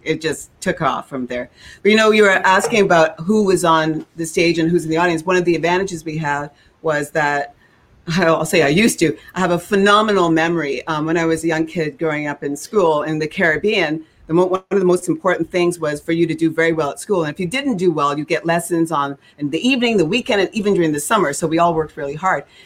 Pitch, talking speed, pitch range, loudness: 165 Hz, 260 wpm, 155-180 Hz, -17 LUFS